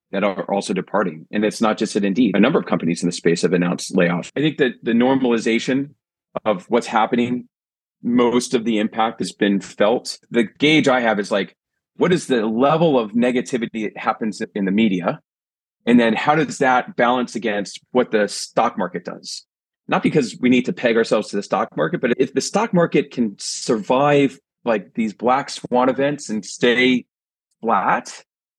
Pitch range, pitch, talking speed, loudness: 105-125 Hz, 115 Hz, 190 wpm, -19 LUFS